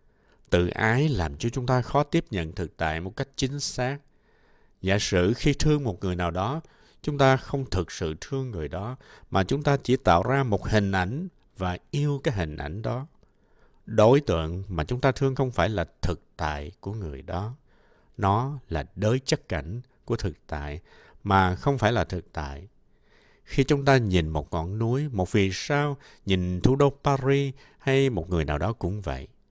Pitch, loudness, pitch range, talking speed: 105 Hz, -26 LUFS, 90-135 Hz, 195 wpm